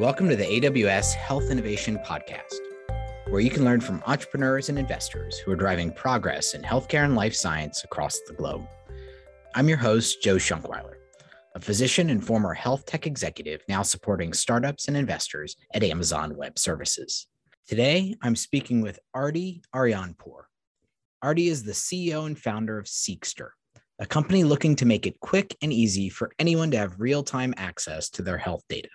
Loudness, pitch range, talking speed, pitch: -26 LUFS, 95-140 Hz, 170 wpm, 115 Hz